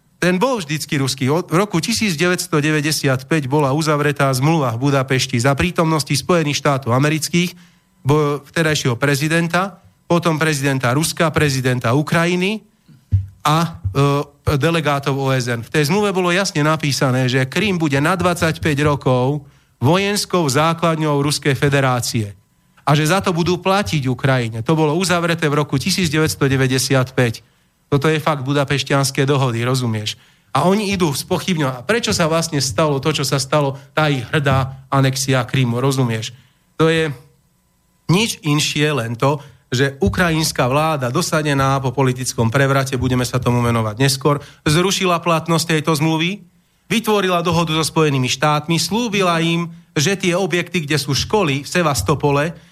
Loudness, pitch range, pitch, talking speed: -17 LUFS, 135-170 Hz, 150 Hz, 135 wpm